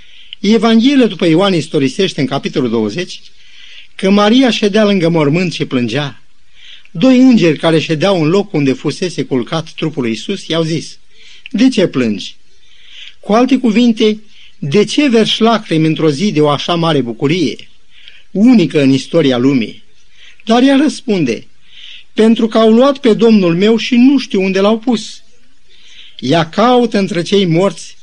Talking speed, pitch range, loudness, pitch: 150 wpm, 155-225 Hz, -12 LUFS, 195 Hz